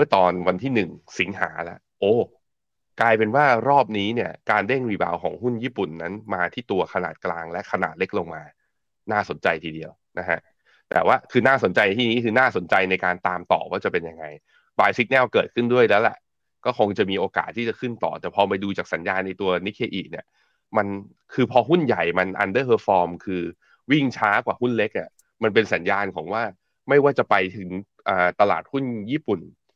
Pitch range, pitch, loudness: 90-120 Hz, 100 Hz, -22 LUFS